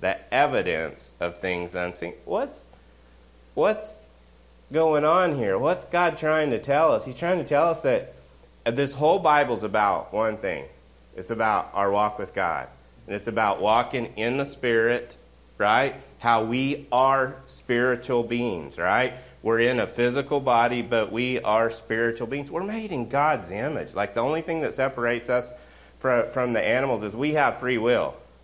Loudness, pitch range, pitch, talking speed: -24 LUFS, 95-140 Hz, 120 Hz, 165 wpm